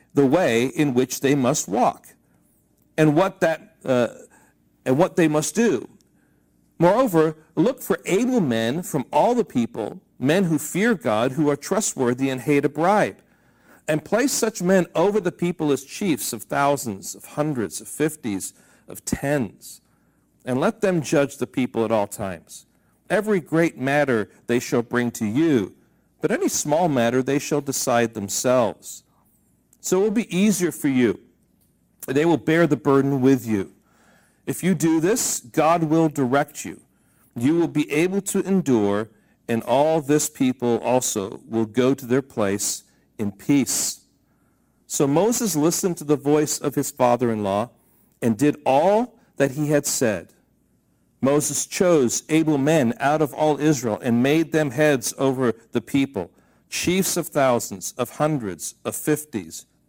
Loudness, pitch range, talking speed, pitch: -22 LUFS, 120-160 Hz, 160 wpm, 145 Hz